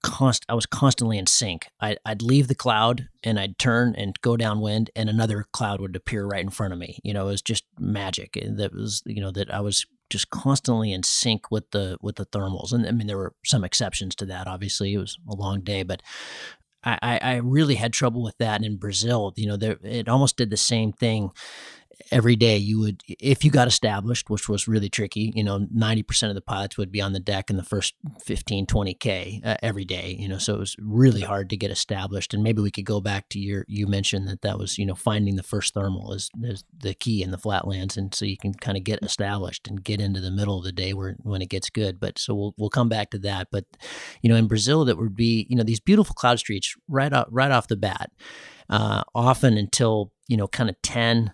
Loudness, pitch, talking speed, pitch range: -24 LUFS, 105 Hz, 240 wpm, 100-115 Hz